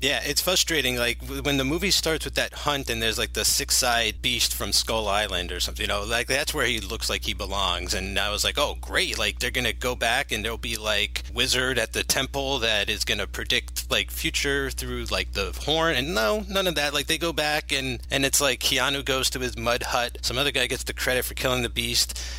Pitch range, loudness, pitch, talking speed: 100-145 Hz, -24 LUFS, 135 Hz, 240 wpm